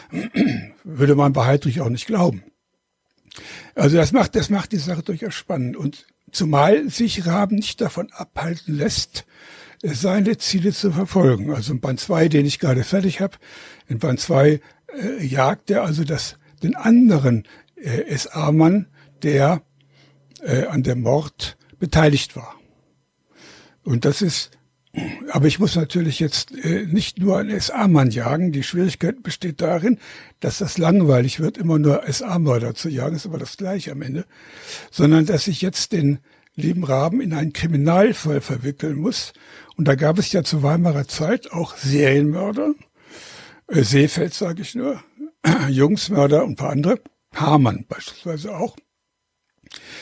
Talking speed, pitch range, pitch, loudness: 150 wpm, 140-190 Hz, 160 Hz, -20 LUFS